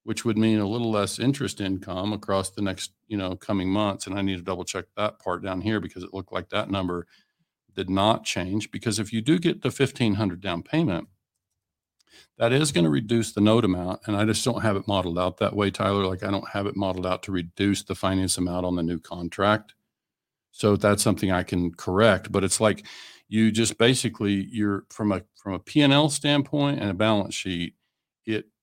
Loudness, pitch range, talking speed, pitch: -25 LUFS, 95-110 Hz, 215 wpm, 100 Hz